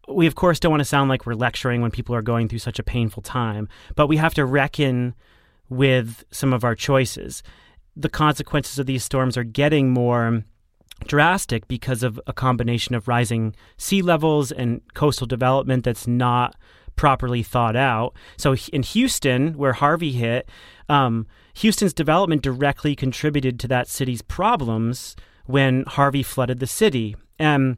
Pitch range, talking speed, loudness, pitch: 120-145 Hz, 160 wpm, -21 LUFS, 130 Hz